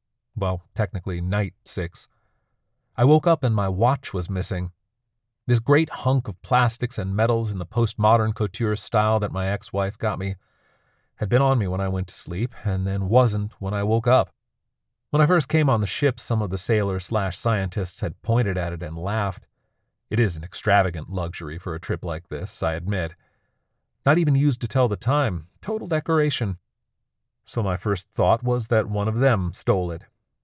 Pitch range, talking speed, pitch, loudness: 95-120 Hz, 190 wpm, 110 Hz, -23 LUFS